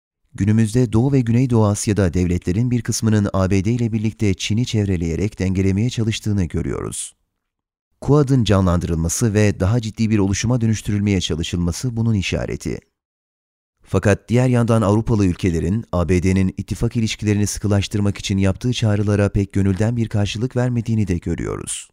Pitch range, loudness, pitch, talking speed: 95-115 Hz, -19 LUFS, 105 Hz, 125 wpm